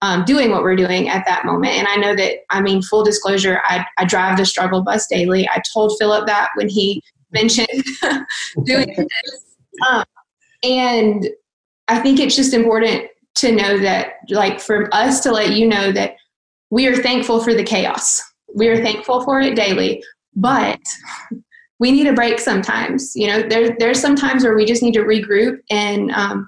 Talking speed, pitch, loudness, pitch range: 185 wpm, 225 Hz, -16 LUFS, 205-250 Hz